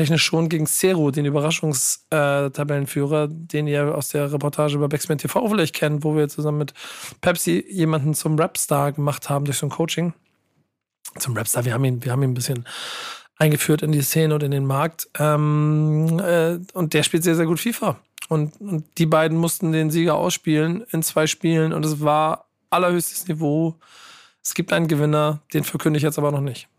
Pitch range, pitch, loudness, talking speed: 145-165 Hz, 155 Hz, -21 LUFS, 190 wpm